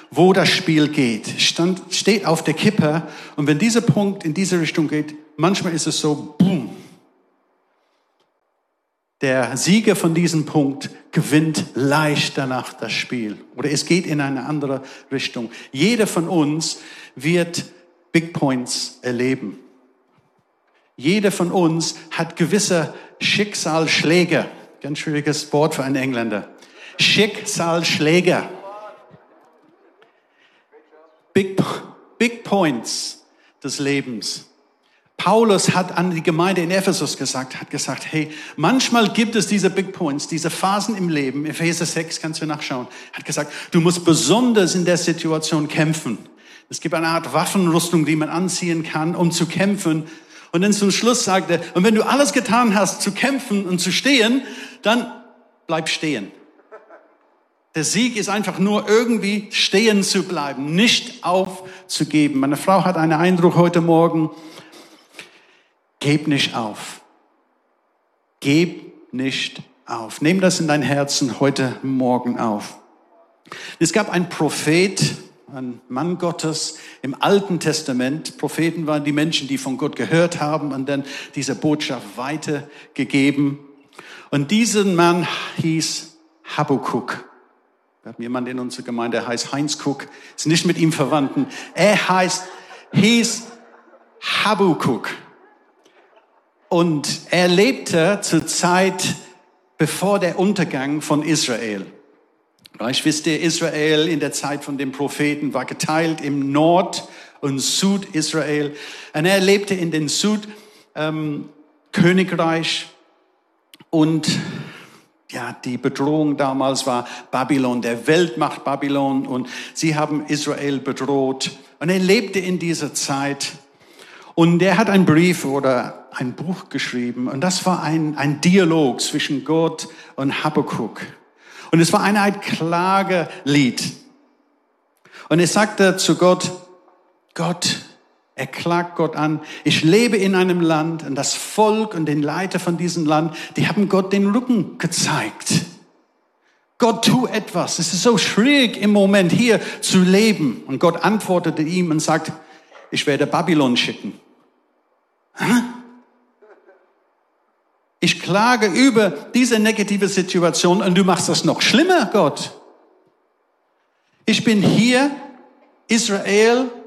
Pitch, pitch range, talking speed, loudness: 165 Hz, 150-190 Hz, 130 wpm, -18 LUFS